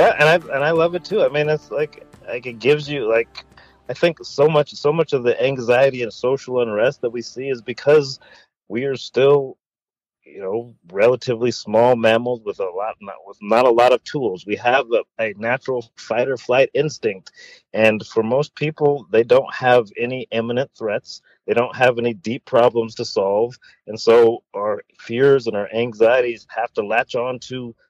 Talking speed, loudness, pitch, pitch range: 195 wpm, -19 LUFS, 130 Hz, 120-160 Hz